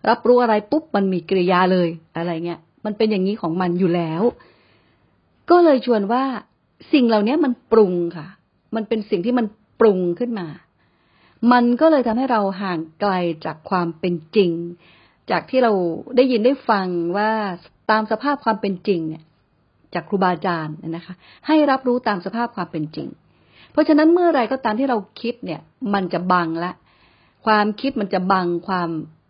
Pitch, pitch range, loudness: 205 Hz, 175-240 Hz, -20 LUFS